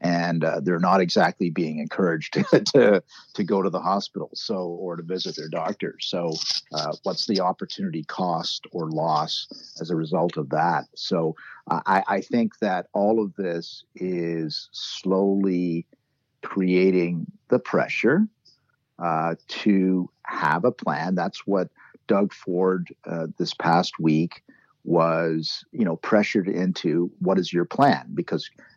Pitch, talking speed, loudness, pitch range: 90 Hz, 145 wpm, -24 LUFS, 85-95 Hz